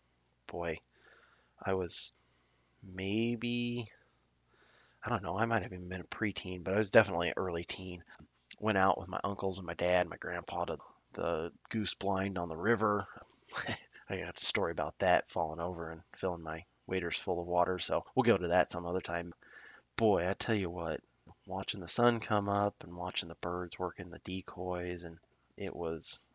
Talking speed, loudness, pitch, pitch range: 185 wpm, -35 LUFS, 90 Hz, 85-100 Hz